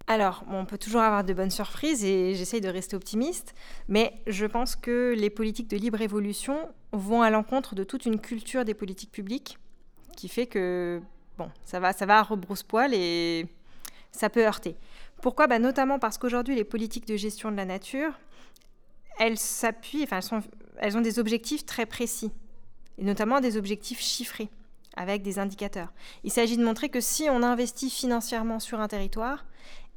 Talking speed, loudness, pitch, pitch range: 180 wpm, -28 LUFS, 220 Hz, 200-240 Hz